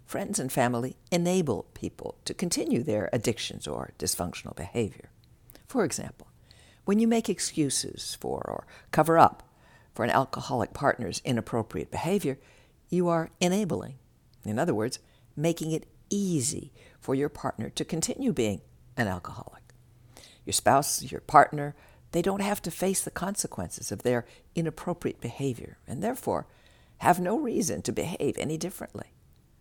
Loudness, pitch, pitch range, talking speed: -29 LUFS, 155 Hz, 125-180 Hz, 140 wpm